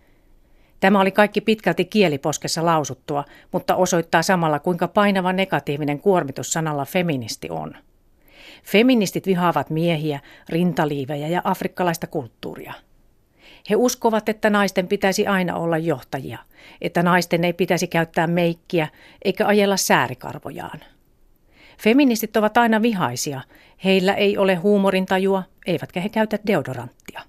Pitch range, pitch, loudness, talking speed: 160-200 Hz, 180 Hz, -20 LUFS, 115 wpm